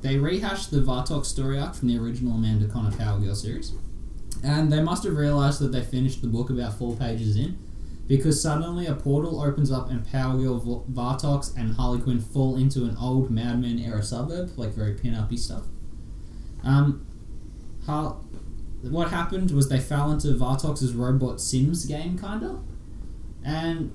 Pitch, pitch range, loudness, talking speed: 125 Hz, 110-145 Hz, -26 LUFS, 175 wpm